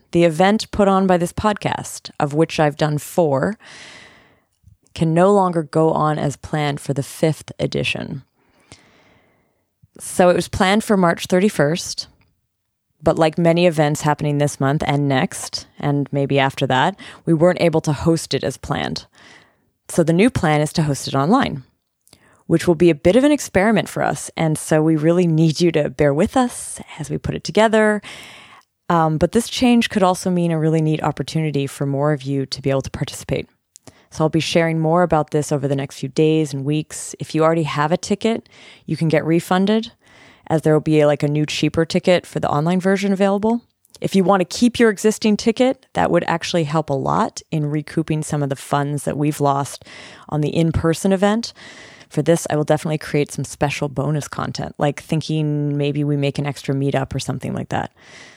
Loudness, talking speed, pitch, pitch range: -19 LUFS, 200 wpm, 155 Hz, 145-175 Hz